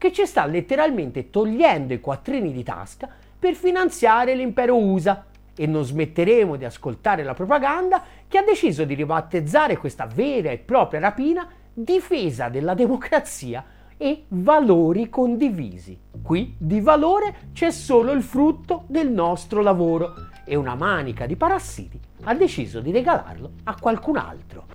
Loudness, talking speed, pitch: -21 LUFS, 140 wpm, 225 Hz